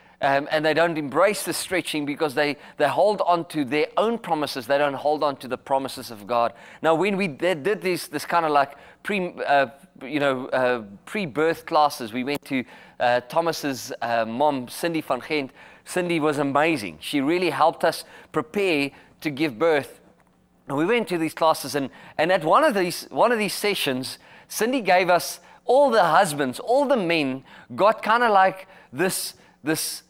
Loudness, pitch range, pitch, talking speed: -23 LUFS, 140-180 Hz, 155 Hz, 185 wpm